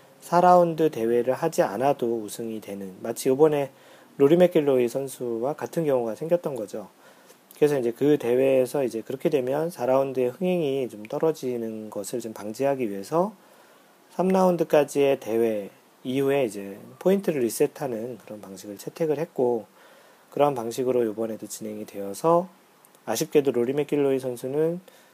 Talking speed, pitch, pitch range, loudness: 330 characters per minute, 135 Hz, 115-155 Hz, -25 LUFS